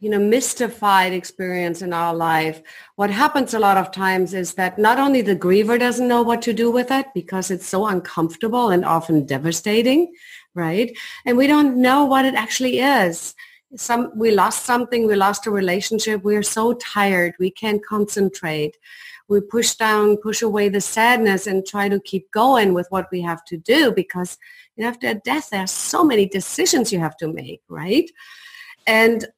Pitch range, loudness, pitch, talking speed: 185-245 Hz, -19 LUFS, 210 Hz, 185 wpm